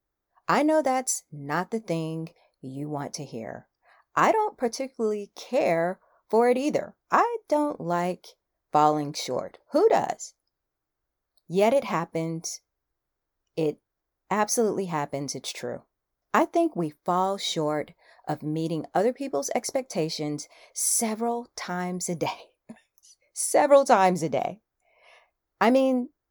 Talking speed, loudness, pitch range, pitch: 120 wpm, -26 LUFS, 160-245 Hz, 180 Hz